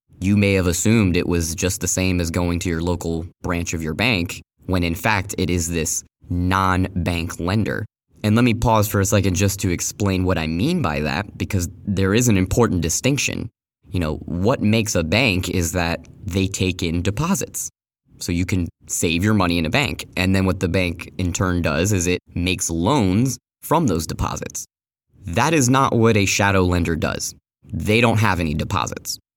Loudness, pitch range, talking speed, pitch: -20 LUFS, 85-105 Hz, 200 wpm, 95 Hz